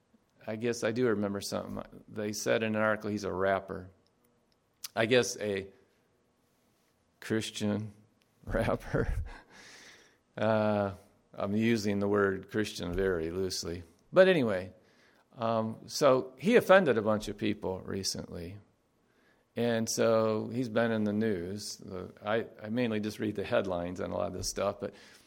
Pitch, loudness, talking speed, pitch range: 105 Hz, -31 LUFS, 145 wpm, 95-115 Hz